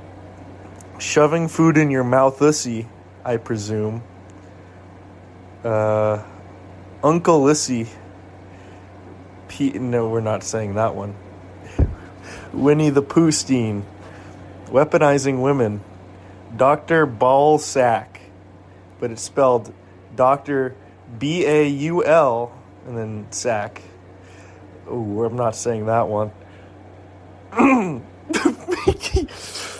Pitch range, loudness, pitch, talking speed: 95-130 Hz, -19 LUFS, 105 Hz, 80 wpm